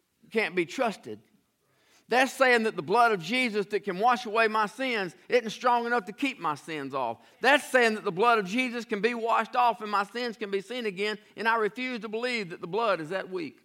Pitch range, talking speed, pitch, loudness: 205-245 Hz, 235 wpm, 225 Hz, -27 LUFS